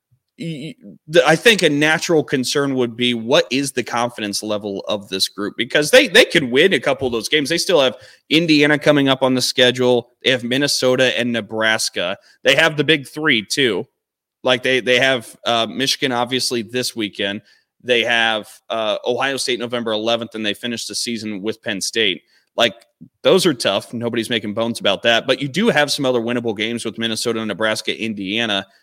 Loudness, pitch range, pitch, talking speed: -17 LUFS, 110-135 Hz, 120 Hz, 185 wpm